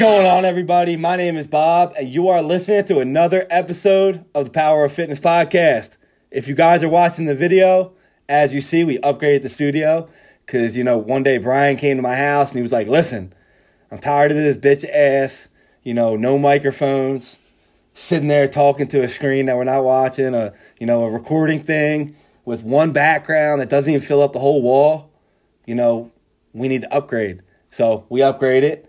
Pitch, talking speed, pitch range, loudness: 145 Hz, 200 wpm, 130-165 Hz, -16 LUFS